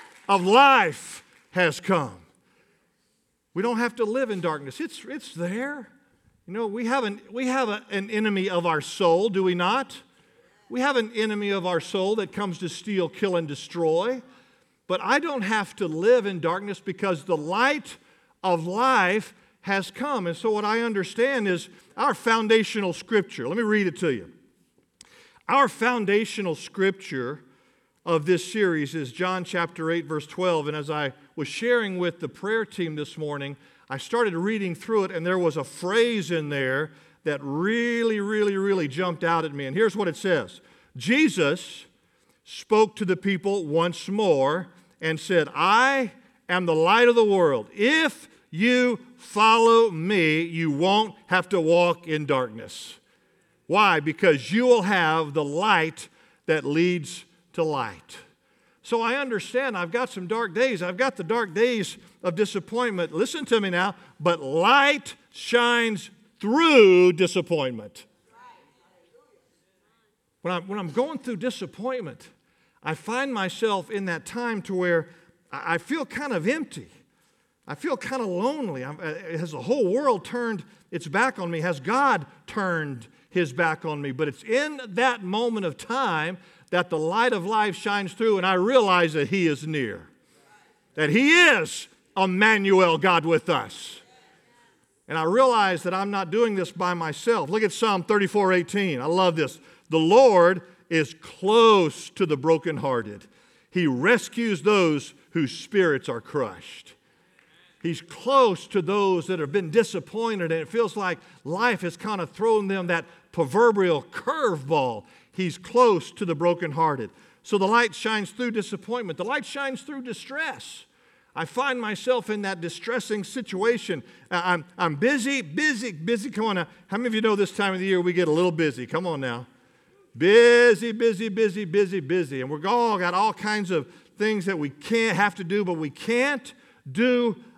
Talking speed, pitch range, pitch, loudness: 165 wpm, 170-230 Hz, 195 Hz, -24 LUFS